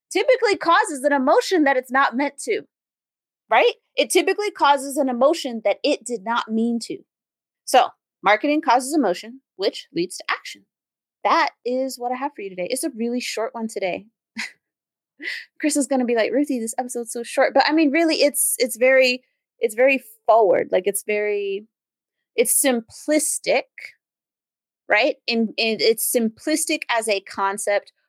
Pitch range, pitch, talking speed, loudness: 230-305 Hz, 265 Hz, 160 wpm, -20 LUFS